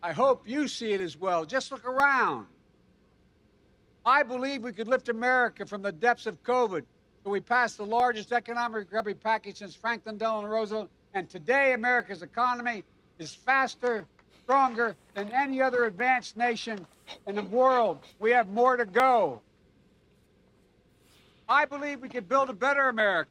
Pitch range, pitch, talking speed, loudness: 210-255 Hz, 240 Hz, 155 wpm, -27 LUFS